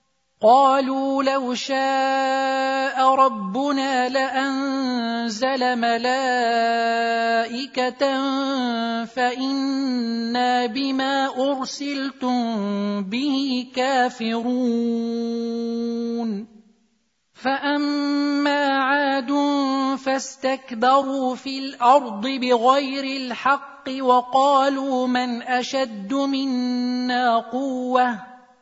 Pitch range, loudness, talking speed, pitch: 240-270 Hz, -21 LUFS, 50 wpm, 260 Hz